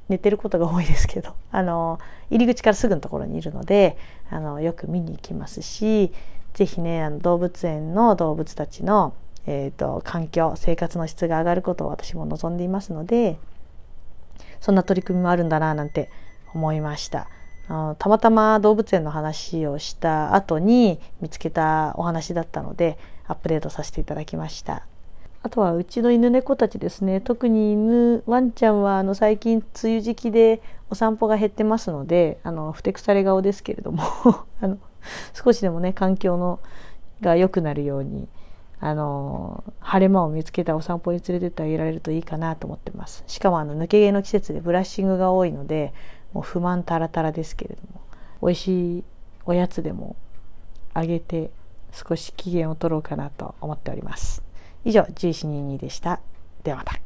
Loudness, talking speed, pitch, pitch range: -22 LUFS, 350 characters per minute, 175 Hz, 155-200 Hz